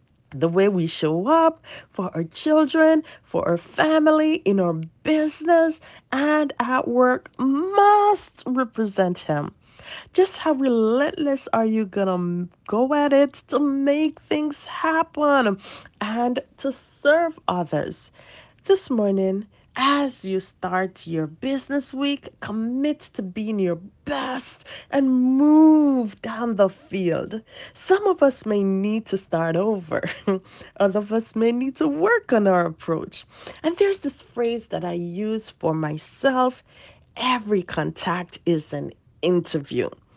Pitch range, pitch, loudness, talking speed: 190-290 Hz, 240 Hz, -22 LUFS, 130 wpm